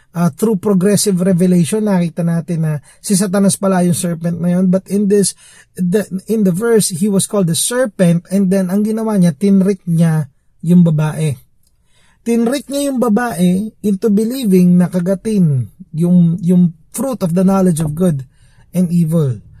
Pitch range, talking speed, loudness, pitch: 170-205 Hz, 160 wpm, -14 LUFS, 185 Hz